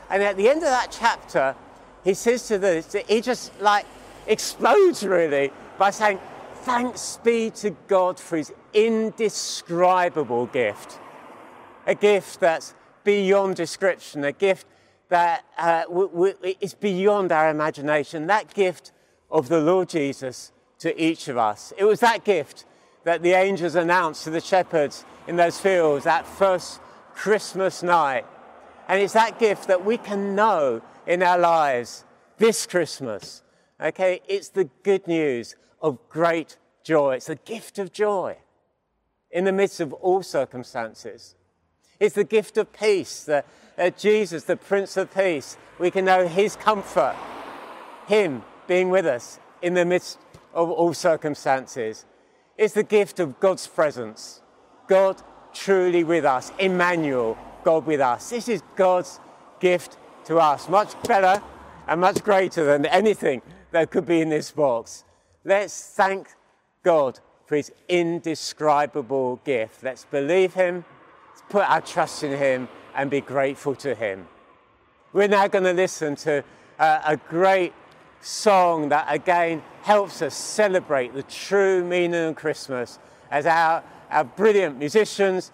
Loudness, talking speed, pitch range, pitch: -22 LUFS, 145 wpm, 155-200 Hz, 180 Hz